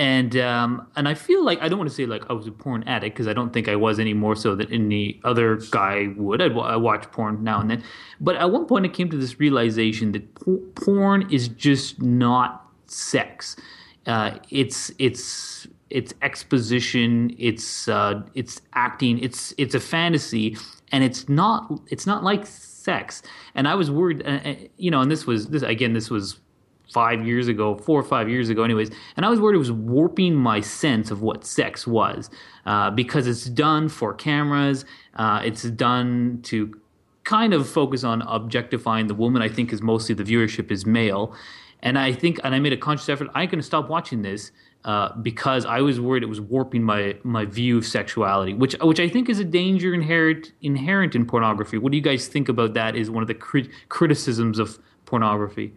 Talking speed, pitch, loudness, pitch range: 205 wpm, 120 Hz, -22 LUFS, 110-145 Hz